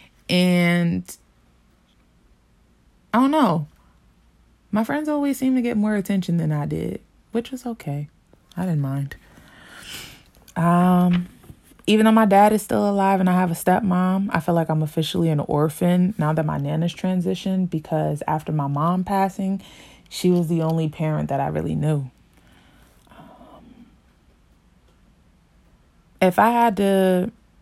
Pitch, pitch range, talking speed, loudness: 175 Hz, 145-195 Hz, 140 wpm, -21 LUFS